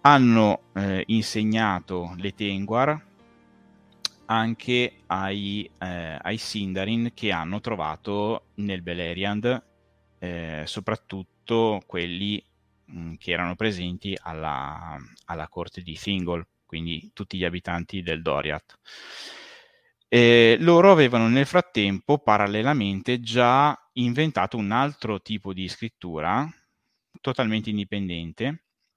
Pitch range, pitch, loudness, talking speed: 90-115 Hz, 100 Hz, -24 LUFS, 95 wpm